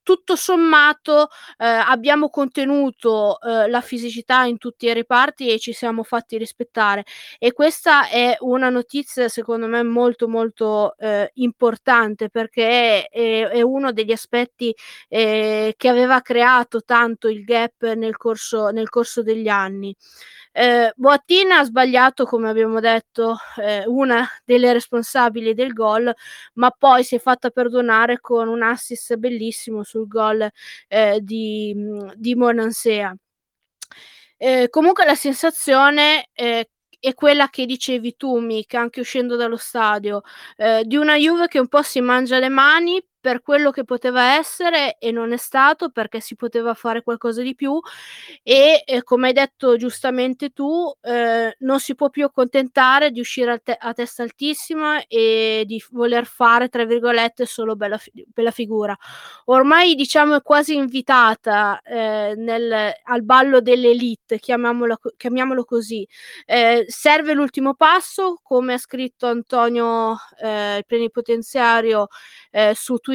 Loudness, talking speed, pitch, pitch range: -17 LUFS, 145 wpm, 240 Hz, 225-265 Hz